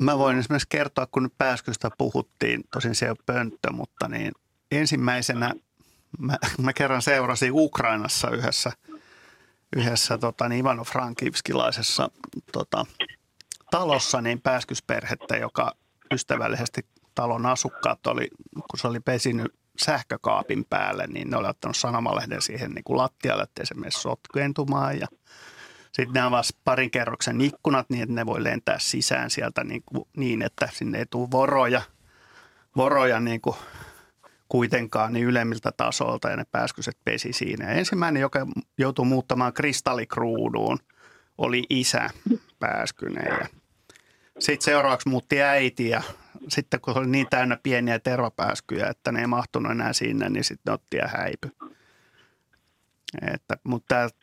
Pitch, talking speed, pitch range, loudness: 130 Hz, 135 wpm, 120-140 Hz, -25 LUFS